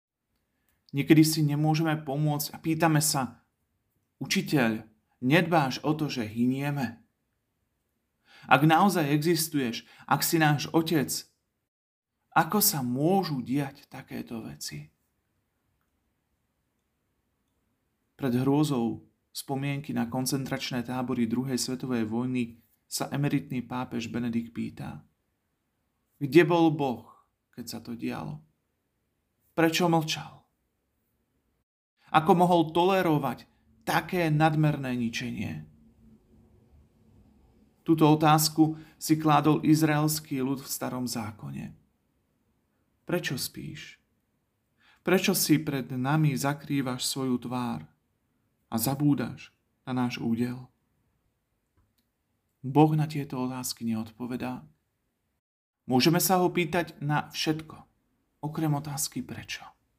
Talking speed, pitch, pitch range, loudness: 90 wpm, 130 Hz, 115-155 Hz, -27 LUFS